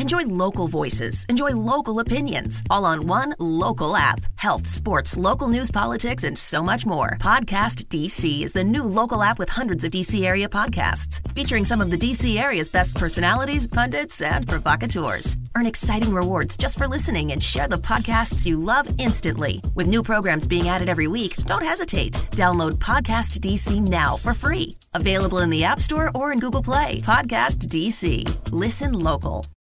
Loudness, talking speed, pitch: -21 LUFS, 170 wpm, 165 Hz